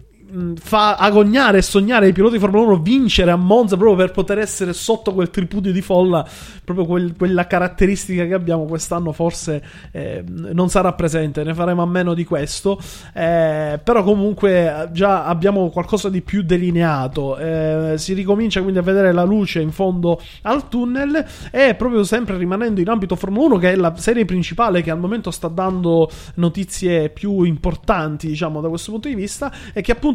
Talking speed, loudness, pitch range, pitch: 180 wpm, -17 LUFS, 170-205 Hz, 185 Hz